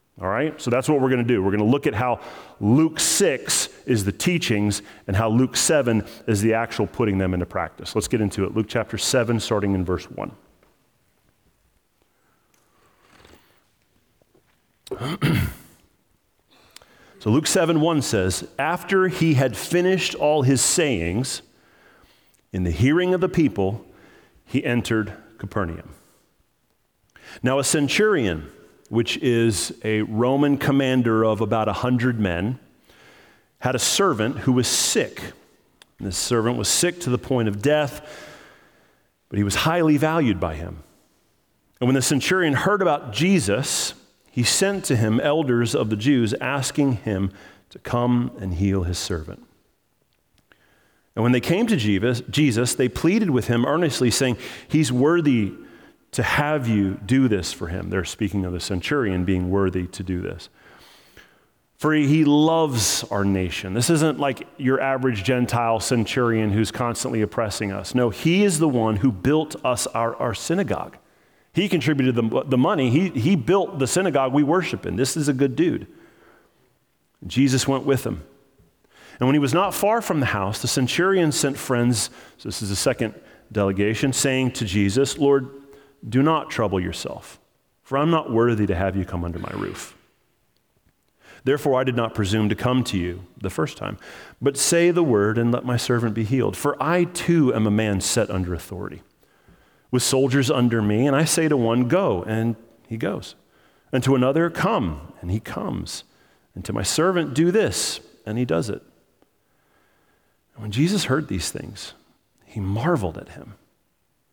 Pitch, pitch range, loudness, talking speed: 120 Hz, 105-145 Hz, -21 LUFS, 165 wpm